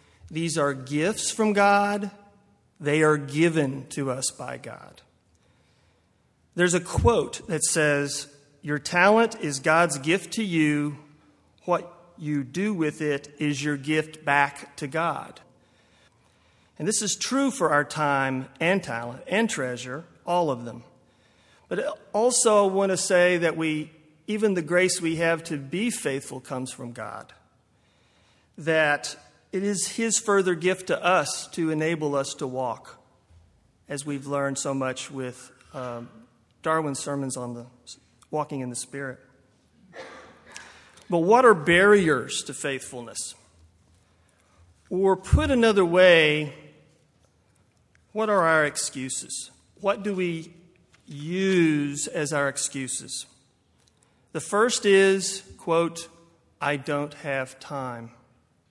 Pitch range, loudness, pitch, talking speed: 135-180 Hz, -24 LUFS, 150 Hz, 130 wpm